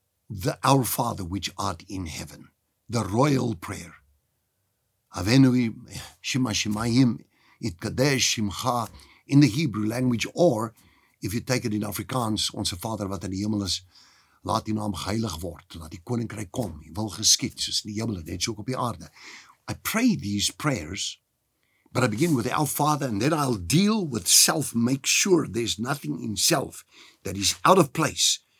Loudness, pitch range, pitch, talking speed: -24 LUFS, 100-130 Hz, 110 Hz, 175 wpm